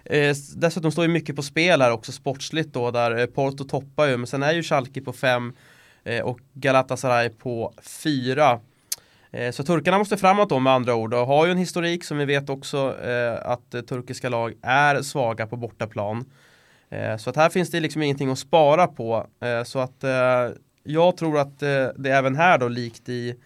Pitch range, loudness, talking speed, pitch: 120-150 Hz, -23 LUFS, 200 wpm, 135 Hz